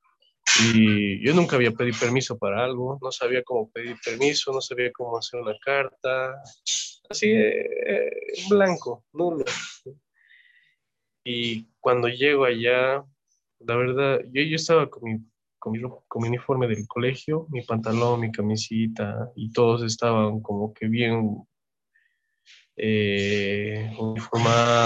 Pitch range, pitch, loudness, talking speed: 110-140 Hz, 120 Hz, -24 LUFS, 130 wpm